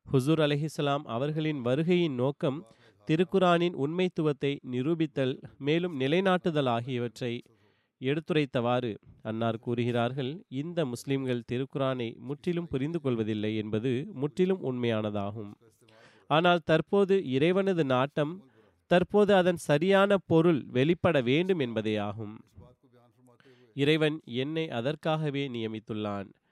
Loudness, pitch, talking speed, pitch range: -29 LUFS, 135 Hz, 85 wpm, 120-160 Hz